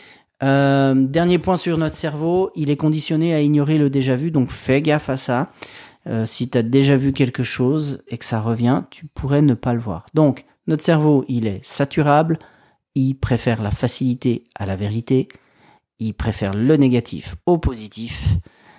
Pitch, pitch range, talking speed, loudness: 135 Hz, 120-150 Hz, 180 wpm, -19 LUFS